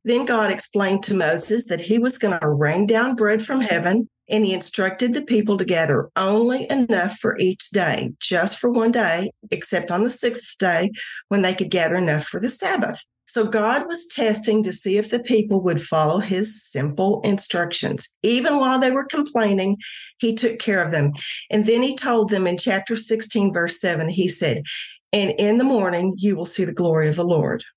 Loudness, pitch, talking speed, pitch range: -19 LUFS, 205 Hz, 200 wpm, 180-230 Hz